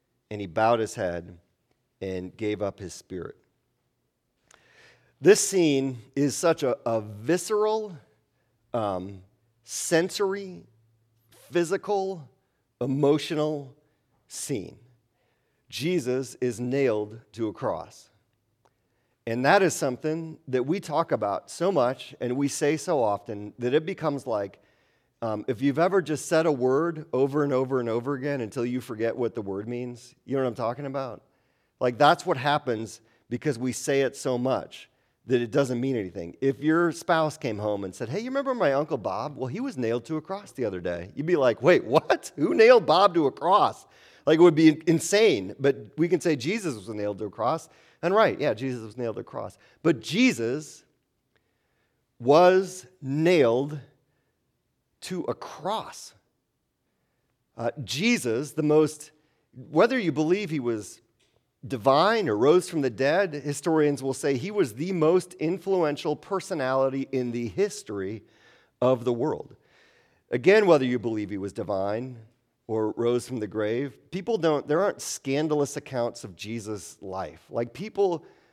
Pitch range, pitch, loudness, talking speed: 115-155 Hz, 135 Hz, -26 LUFS, 160 wpm